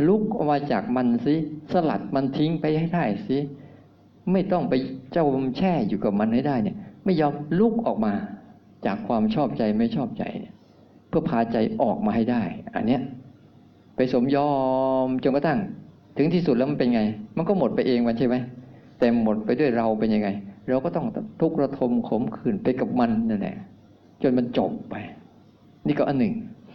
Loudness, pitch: -24 LUFS, 150 Hz